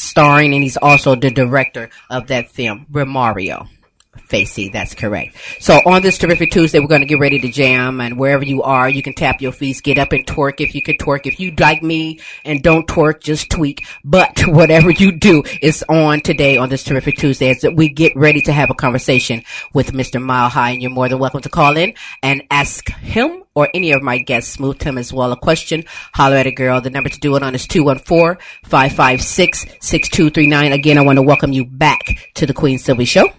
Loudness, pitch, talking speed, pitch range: -13 LUFS, 140 Hz, 215 wpm, 130-155 Hz